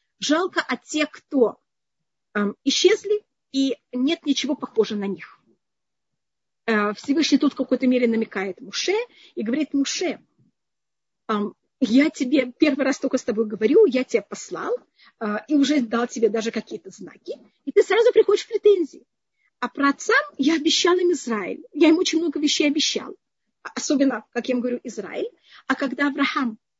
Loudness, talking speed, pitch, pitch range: -22 LUFS, 165 wpm, 275 Hz, 235-320 Hz